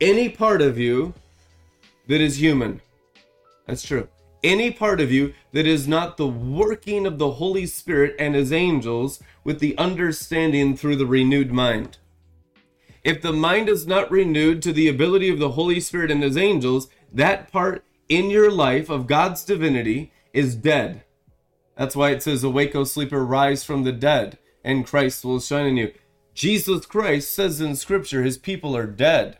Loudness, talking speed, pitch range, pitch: -21 LUFS, 170 wpm, 130-175 Hz, 145 Hz